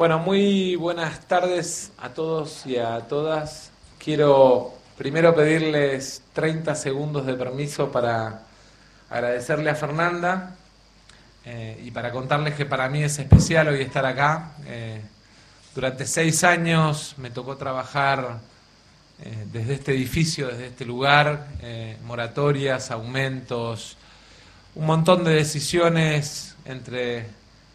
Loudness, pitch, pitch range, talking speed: -22 LUFS, 140 Hz, 125-155 Hz, 115 wpm